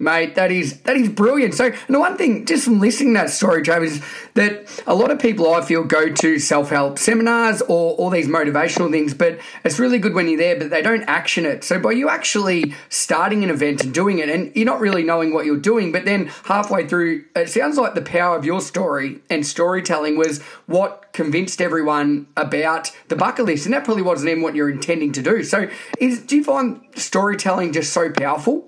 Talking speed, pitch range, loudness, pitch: 220 wpm, 160-225 Hz, -18 LUFS, 175 Hz